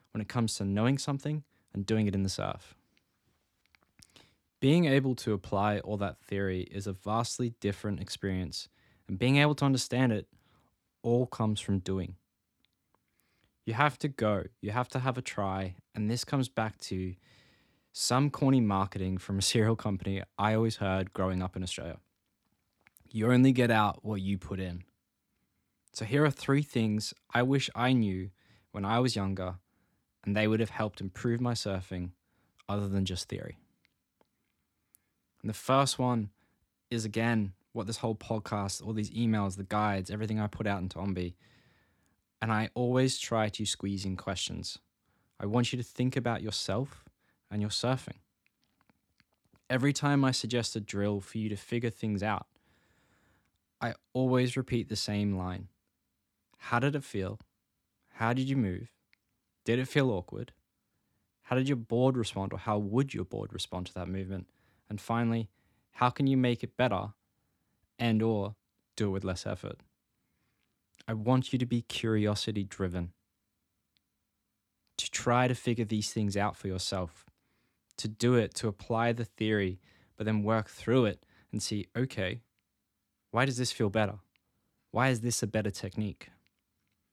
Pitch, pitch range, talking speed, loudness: 105 Hz, 95-120 Hz, 165 wpm, -32 LUFS